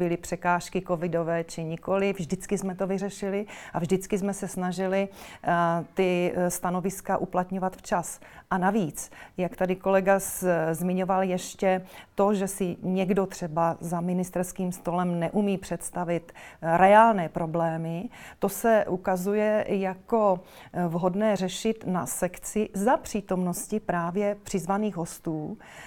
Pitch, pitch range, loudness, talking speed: 185 Hz, 175-195 Hz, -27 LUFS, 115 wpm